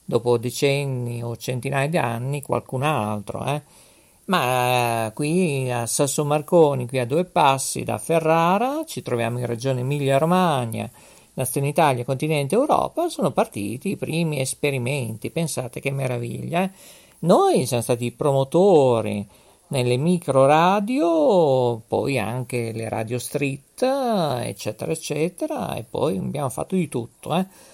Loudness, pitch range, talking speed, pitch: -22 LUFS, 120-165 Hz, 130 wpm, 135 Hz